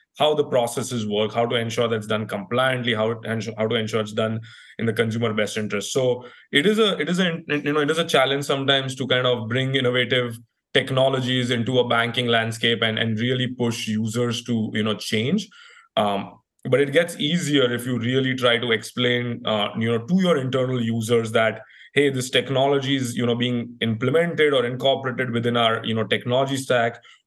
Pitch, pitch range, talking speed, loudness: 120 Hz, 115-135 Hz, 200 wpm, -22 LUFS